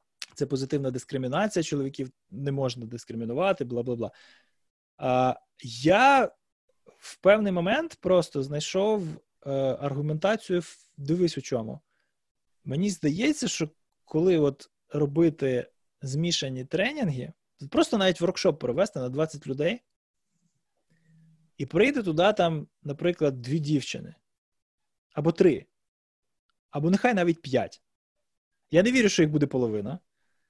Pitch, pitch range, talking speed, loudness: 155 Hz, 135-180 Hz, 105 wpm, -26 LUFS